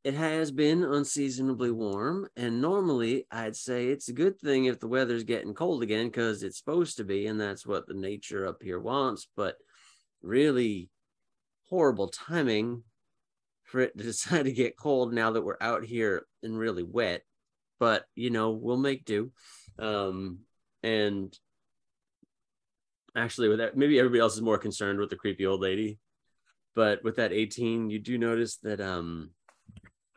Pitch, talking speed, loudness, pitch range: 115 Hz, 165 wpm, -30 LUFS, 105-125 Hz